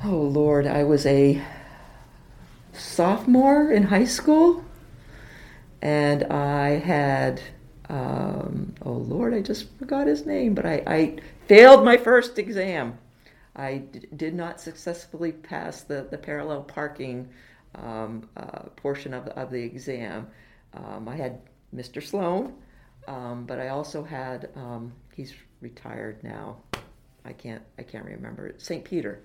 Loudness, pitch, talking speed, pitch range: -21 LUFS, 145 Hz, 135 wpm, 130-190 Hz